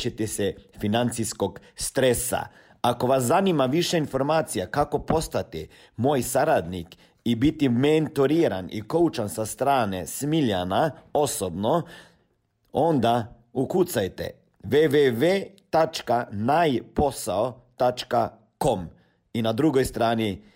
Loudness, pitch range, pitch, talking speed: -24 LUFS, 110-150 Hz, 125 Hz, 85 wpm